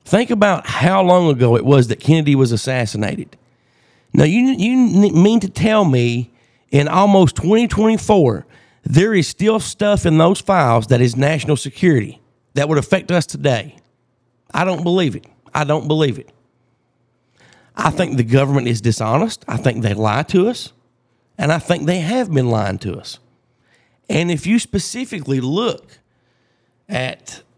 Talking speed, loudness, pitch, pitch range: 155 wpm, -16 LUFS, 150 Hz, 125-190 Hz